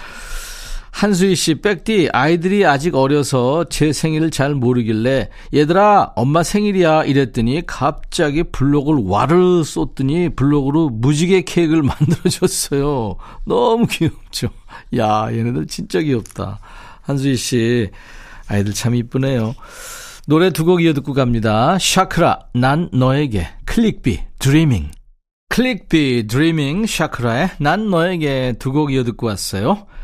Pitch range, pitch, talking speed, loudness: 125-175 Hz, 145 Hz, 275 characters per minute, -16 LUFS